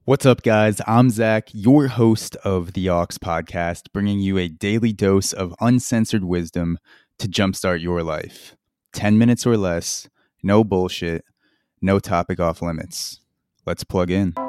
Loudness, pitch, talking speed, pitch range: -20 LUFS, 95 Hz, 150 wpm, 85-110 Hz